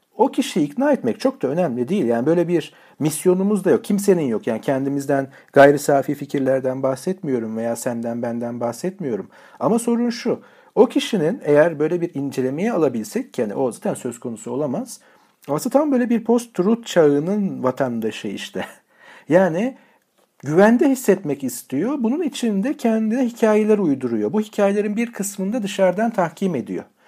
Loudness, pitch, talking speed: -20 LUFS, 185 Hz, 150 wpm